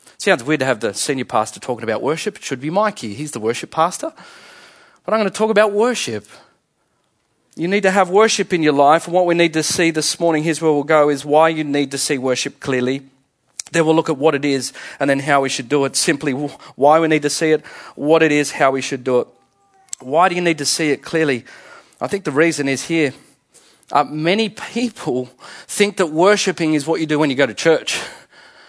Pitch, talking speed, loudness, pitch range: 155 Hz, 230 wpm, -17 LUFS, 140-185 Hz